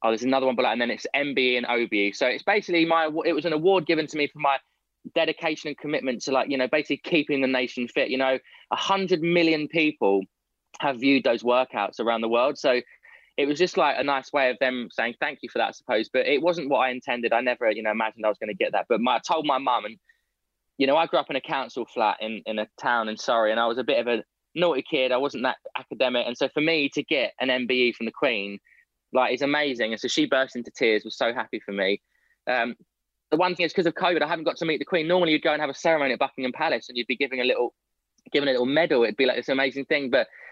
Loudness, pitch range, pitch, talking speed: -24 LUFS, 120-160 Hz, 135 Hz, 275 wpm